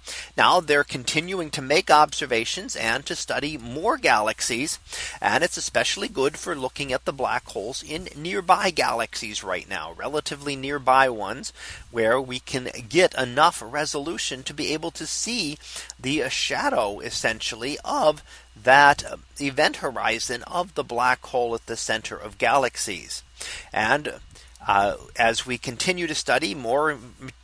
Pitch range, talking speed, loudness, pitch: 130-155 Hz, 140 wpm, -23 LUFS, 145 Hz